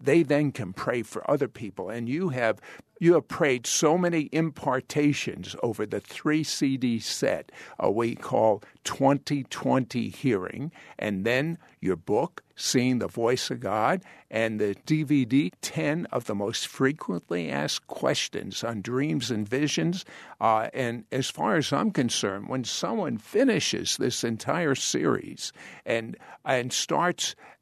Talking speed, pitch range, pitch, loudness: 145 wpm, 115-150 Hz, 130 Hz, -27 LUFS